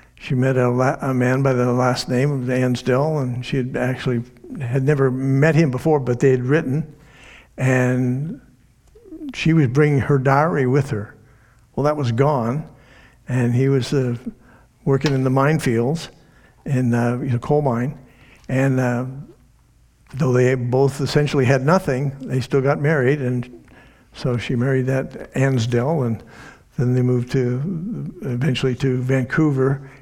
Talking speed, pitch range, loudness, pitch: 150 wpm, 125-140 Hz, -20 LUFS, 130 Hz